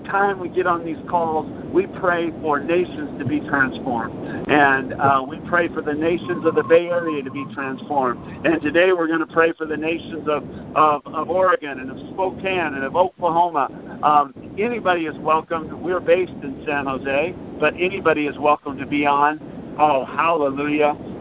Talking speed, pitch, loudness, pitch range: 180 wpm, 160 Hz, -20 LUFS, 145-175 Hz